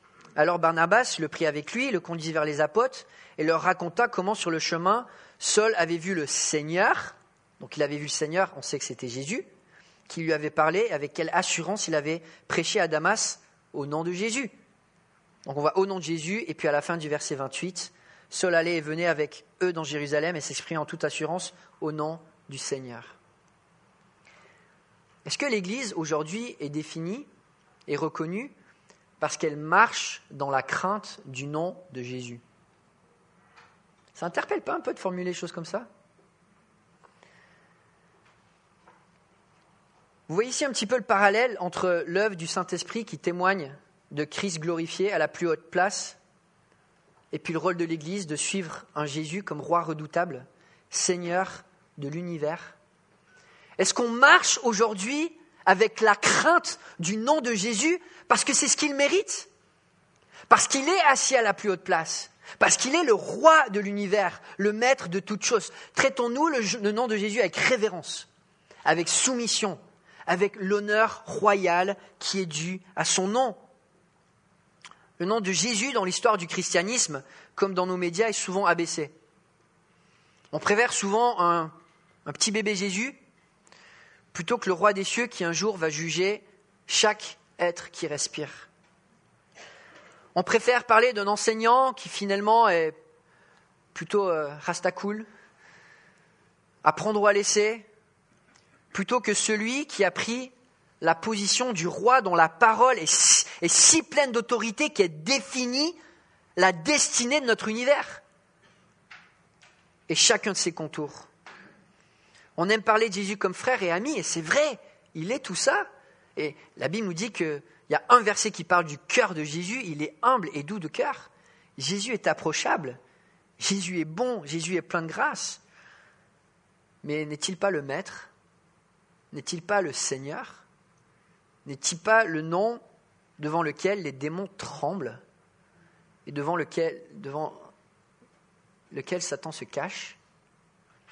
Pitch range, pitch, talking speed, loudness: 165-220 Hz, 185 Hz, 155 wpm, -25 LUFS